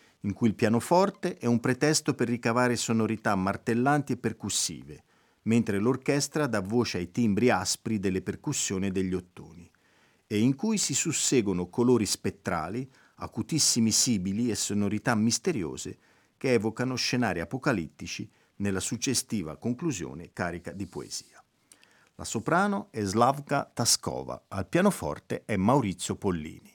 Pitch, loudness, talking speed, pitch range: 115 Hz, -28 LUFS, 130 wpm, 100-130 Hz